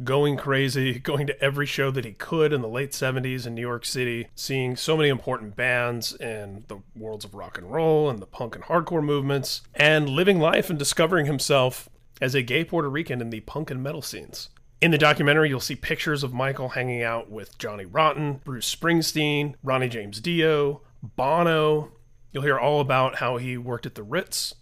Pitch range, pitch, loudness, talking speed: 120-150 Hz, 135 Hz, -24 LUFS, 195 wpm